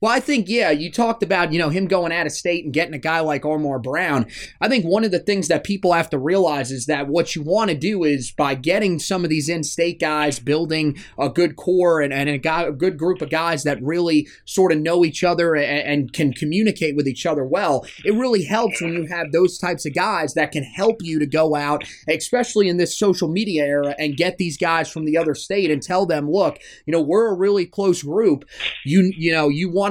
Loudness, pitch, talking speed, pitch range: -20 LUFS, 165 Hz, 245 wpm, 150-185 Hz